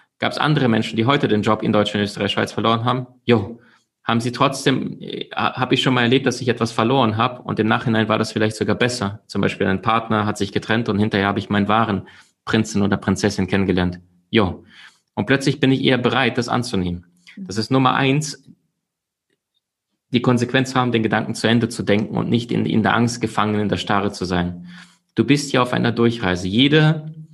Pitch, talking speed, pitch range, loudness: 110 Hz, 210 wpm, 100-125 Hz, -19 LUFS